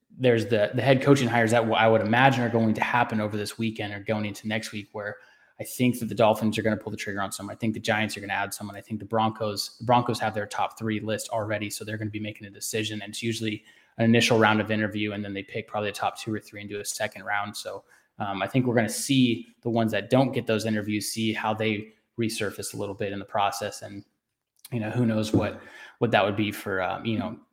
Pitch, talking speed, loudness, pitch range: 110 Hz, 275 wpm, -26 LUFS, 105-115 Hz